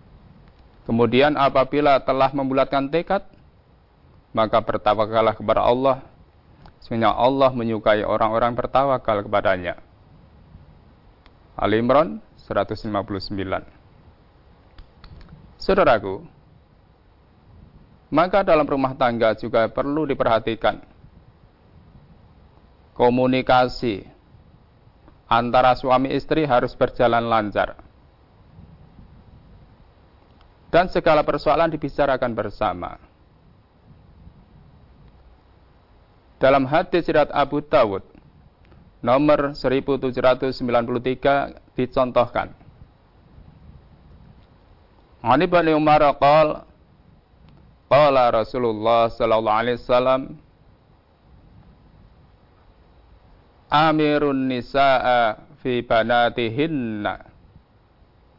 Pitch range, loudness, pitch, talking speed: 100-135 Hz, -20 LUFS, 120 Hz, 60 wpm